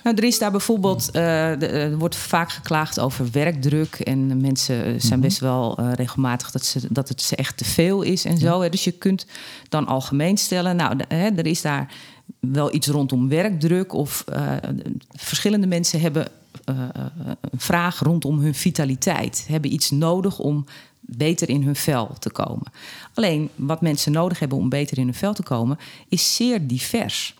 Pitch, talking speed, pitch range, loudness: 150 Hz, 170 wpm, 130-175 Hz, -21 LUFS